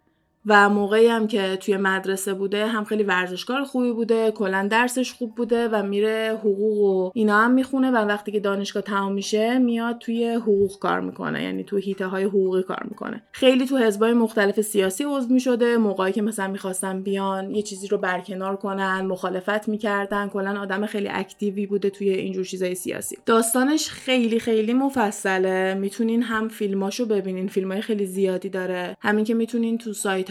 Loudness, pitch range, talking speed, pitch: -23 LUFS, 195-230 Hz, 170 wpm, 205 Hz